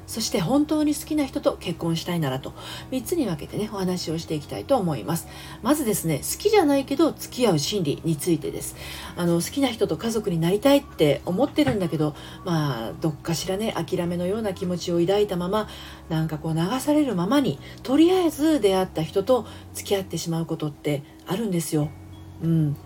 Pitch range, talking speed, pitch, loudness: 160-250 Hz, 405 characters per minute, 180 Hz, -24 LUFS